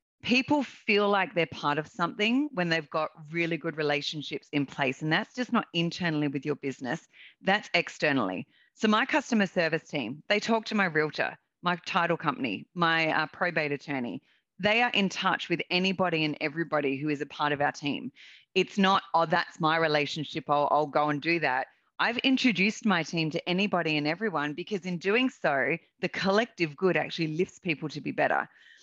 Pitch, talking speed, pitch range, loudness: 170 Hz, 185 wpm, 150-200 Hz, -28 LUFS